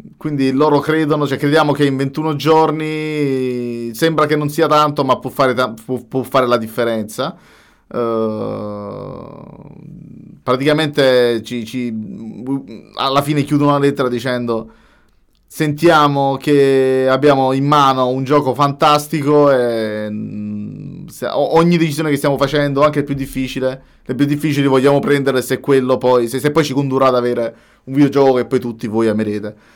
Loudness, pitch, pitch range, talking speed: -15 LUFS, 135 Hz, 125-145 Hz, 145 wpm